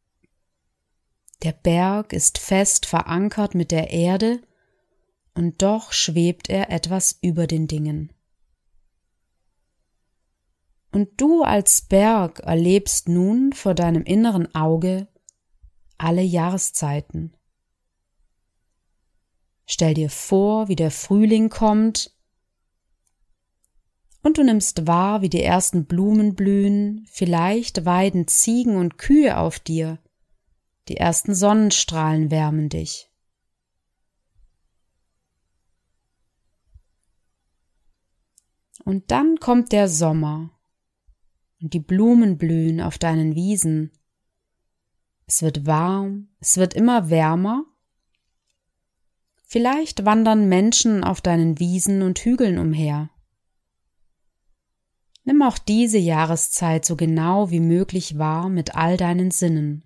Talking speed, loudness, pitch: 95 wpm, -19 LUFS, 170 Hz